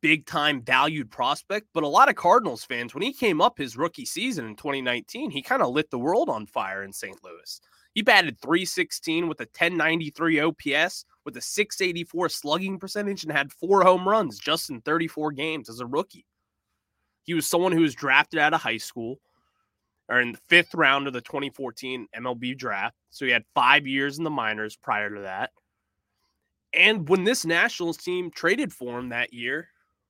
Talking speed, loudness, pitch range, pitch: 190 wpm, -24 LUFS, 125-170 Hz, 155 Hz